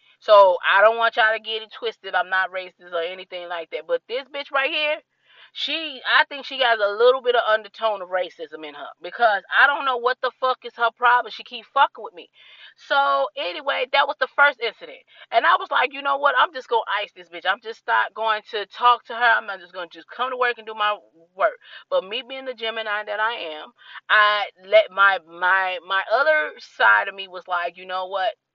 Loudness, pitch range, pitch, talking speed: -21 LUFS, 190-265 Hz, 225 Hz, 235 wpm